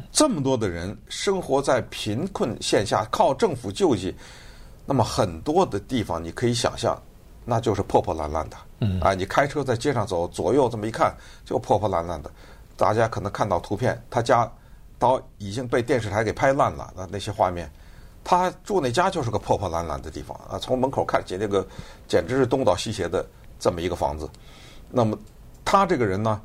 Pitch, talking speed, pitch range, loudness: 105 Hz, 290 characters per minute, 95-130 Hz, -24 LUFS